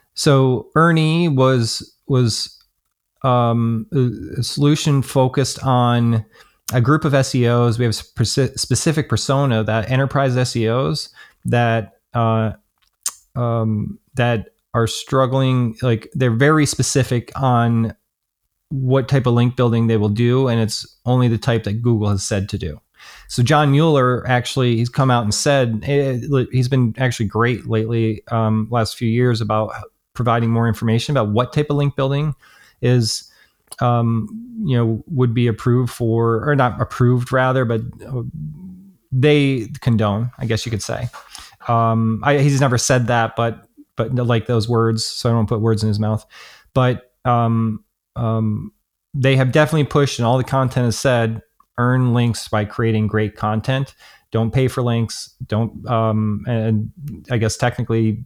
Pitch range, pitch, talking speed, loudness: 115-130 Hz, 120 Hz, 150 wpm, -18 LUFS